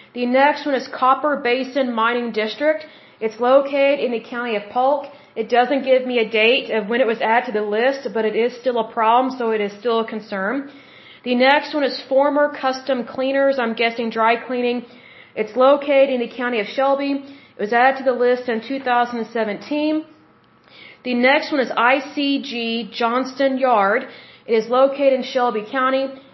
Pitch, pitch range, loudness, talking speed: 255 Hz, 235-270 Hz, -19 LUFS, 180 wpm